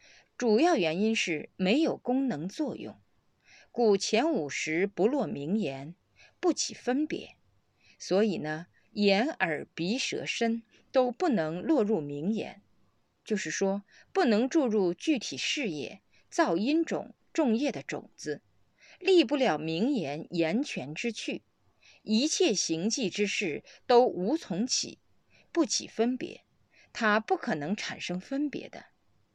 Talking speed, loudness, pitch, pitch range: 185 characters per minute, -29 LUFS, 220 Hz, 180-260 Hz